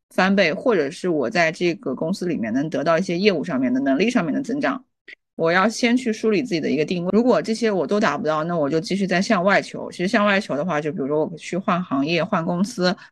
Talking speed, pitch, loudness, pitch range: 365 characters per minute, 185 Hz, -21 LUFS, 165-220 Hz